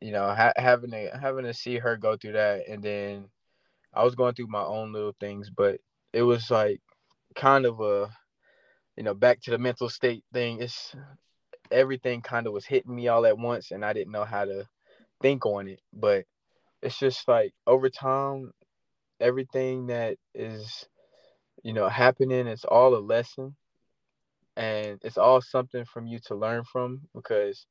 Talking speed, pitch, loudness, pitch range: 180 wpm, 120 Hz, -26 LUFS, 110-130 Hz